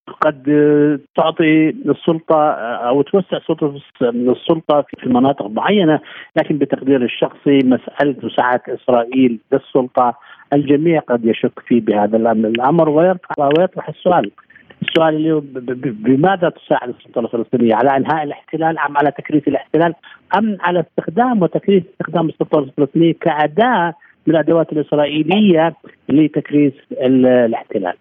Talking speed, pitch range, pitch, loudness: 110 wpm, 130-165 Hz, 150 Hz, -15 LUFS